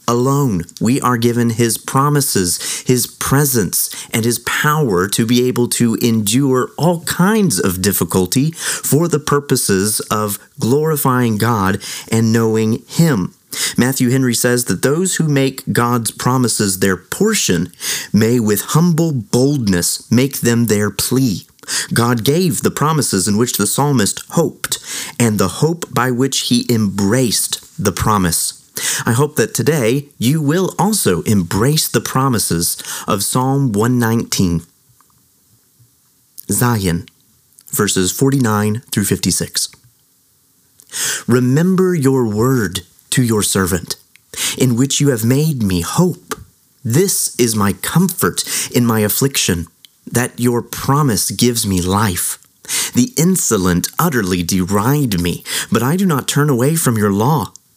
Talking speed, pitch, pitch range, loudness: 130 wpm, 120 Hz, 105-140 Hz, -15 LUFS